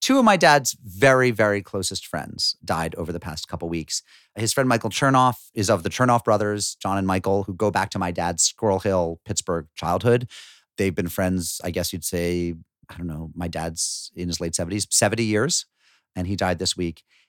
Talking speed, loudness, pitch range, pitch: 205 wpm, -22 LUFS, 85-110 Hz, 95 Hz